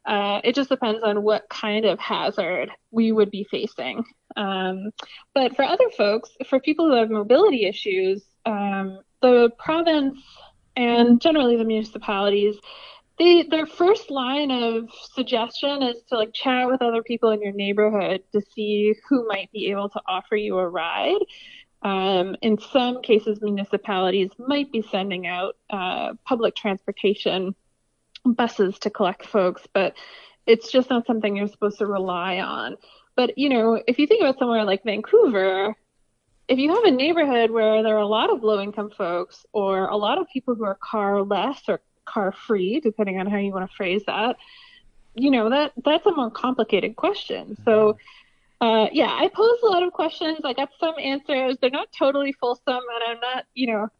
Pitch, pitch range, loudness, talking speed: 225 Hz, 205-270 Hz, -22 LUFS, 175 wpm